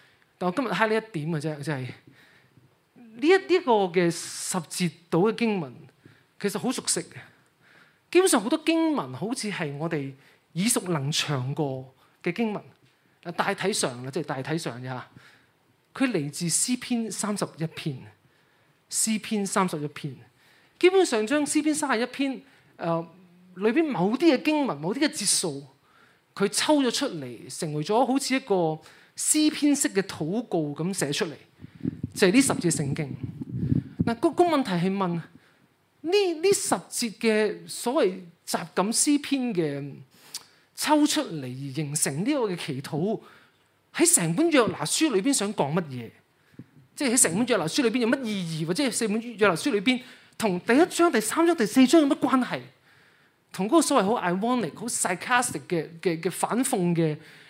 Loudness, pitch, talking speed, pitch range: -25 LUFS, 190 Hz, 245 characters per minute, 155-250 Hz